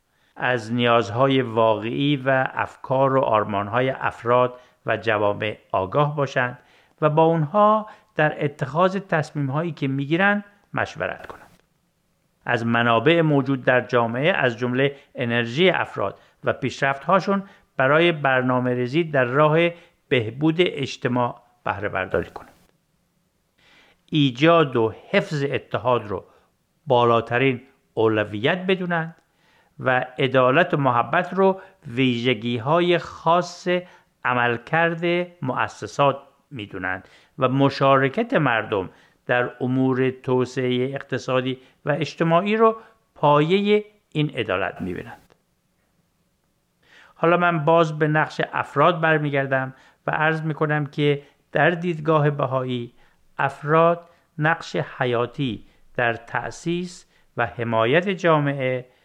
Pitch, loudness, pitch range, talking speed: 140 Hz, -21 LUFS, 125-165 Hz, 100 wpm